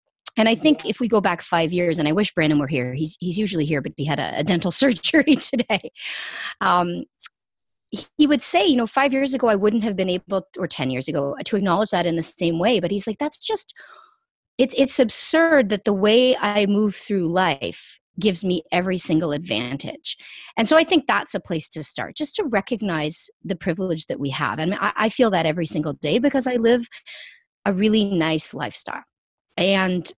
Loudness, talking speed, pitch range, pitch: -21 LUFS, 205 wpm, 170-245 Hz, 200 Hz